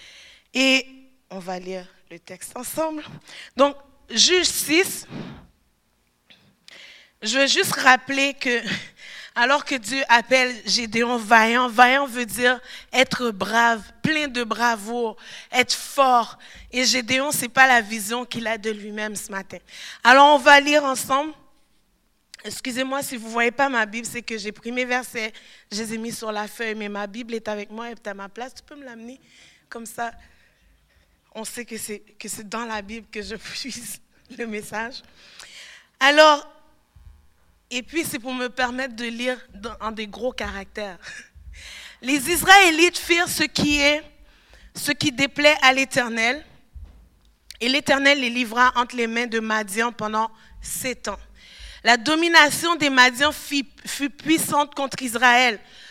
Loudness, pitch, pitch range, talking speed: -20 LUFS, 245 Hz, 220-275 Hz, 155 wpm